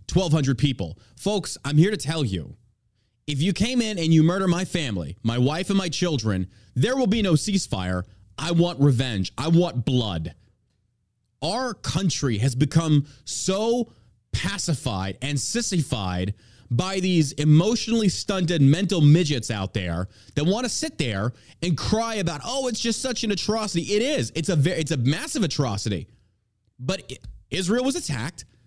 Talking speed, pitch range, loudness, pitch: 160 wpm, 115-190 Hz, -24 LUFS, 150 Hz